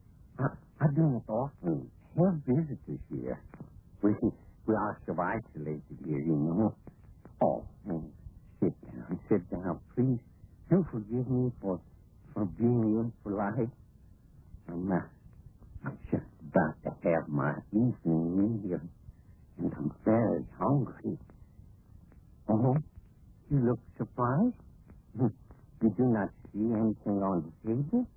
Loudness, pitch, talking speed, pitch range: -32 LUFS, 105 Hz, 120 wpm, 90-120 Hz